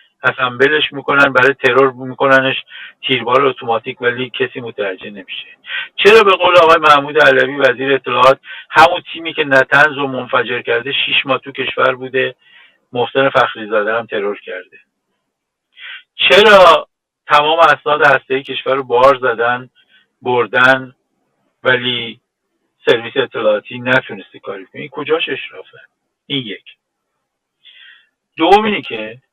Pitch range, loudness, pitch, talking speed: 120-150 Hz, -12 LUFS, 130 Hz, 120 wpm